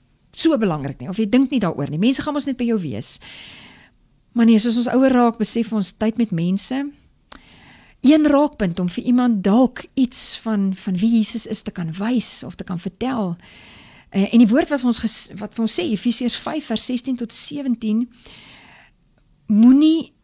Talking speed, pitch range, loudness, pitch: 180 wpm, 210-255 Hz, -19 LUFS, 230 Hz